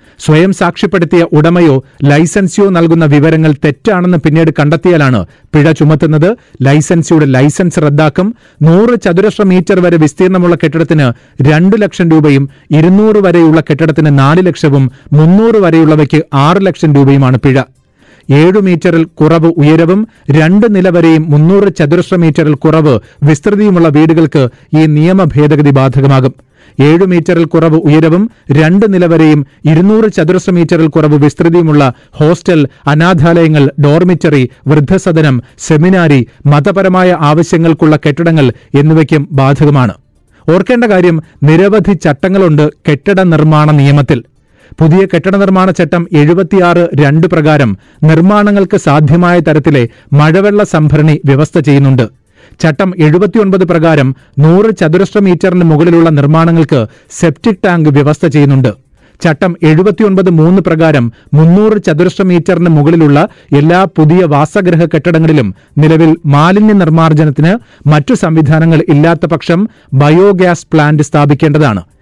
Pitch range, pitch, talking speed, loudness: 150-180 Hz, 160 Hz, 105 wpm, -7 LUFS